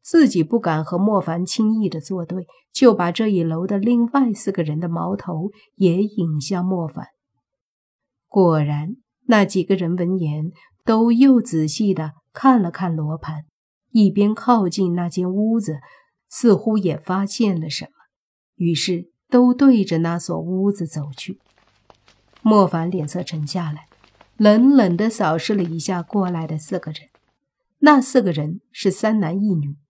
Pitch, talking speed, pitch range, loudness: 185 Hz, 215 characters per minute, 165-215 Hz, -19 LUFS